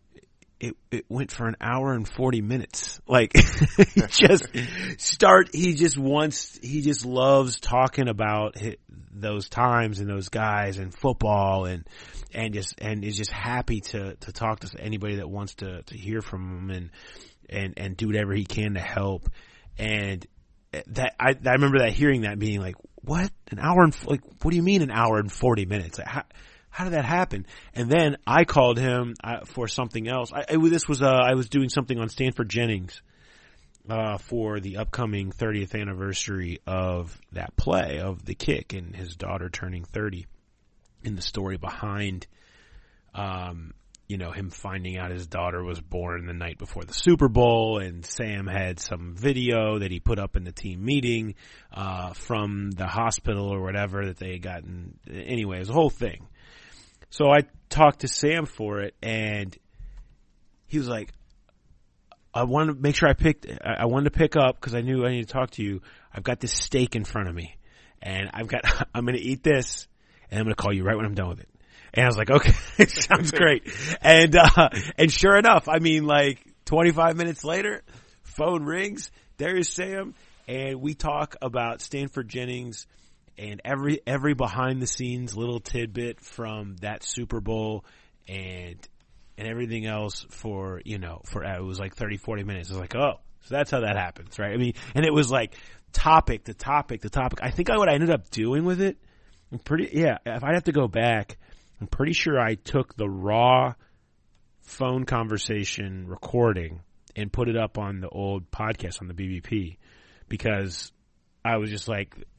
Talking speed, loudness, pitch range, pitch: 190 wpm, -24 LUFS, 95-130 Hz, 110 Hz